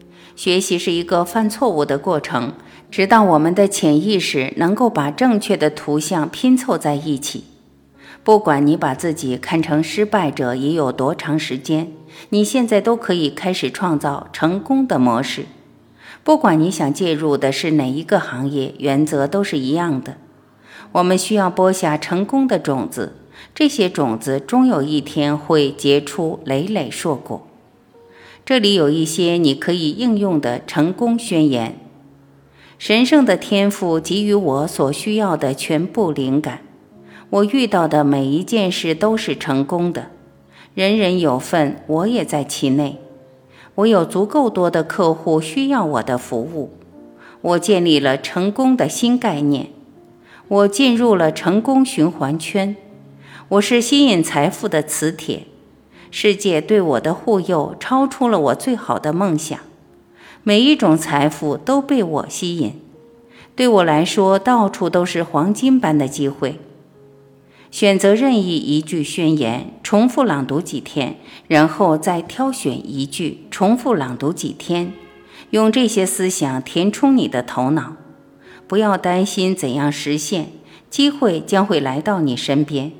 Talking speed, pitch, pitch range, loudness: 215 characters per minute, 165 Hz, 145-205 Hz, -17 LUFS